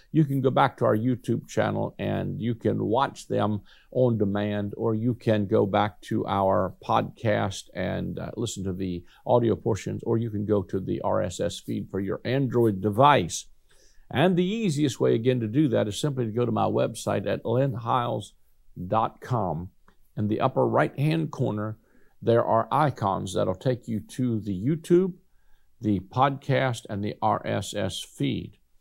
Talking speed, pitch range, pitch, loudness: 165 wpm, 105-130 Hz, 115 Hz, -26 LUFS